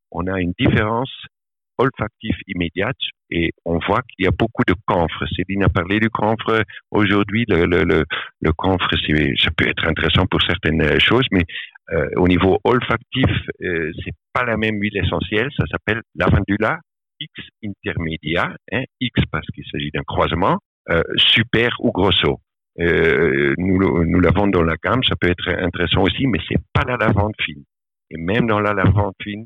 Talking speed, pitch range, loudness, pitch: 175 wpm, 85-105 Hz, -18 LUFS, 95 Hz